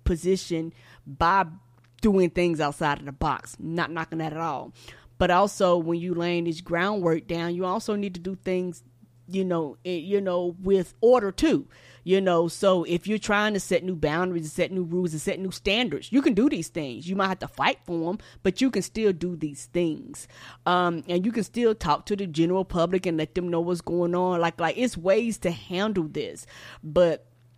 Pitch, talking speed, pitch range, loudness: 175 Hz, 210 wpm, 165-195 Hz, -26 LUFS